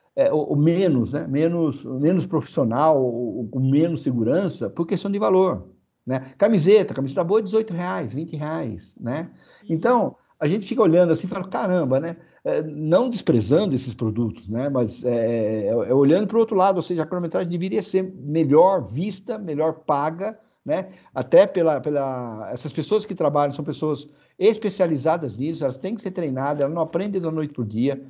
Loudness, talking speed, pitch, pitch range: -22 LUFS, 185 wpm, 160 Hz, 140-185 Hz